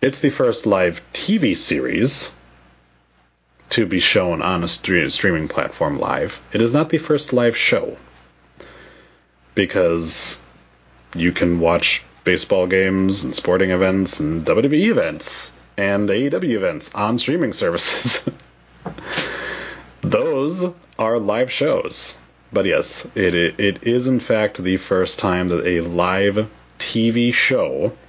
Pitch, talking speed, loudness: 95 Hz, 130 wpm, -18 LUFS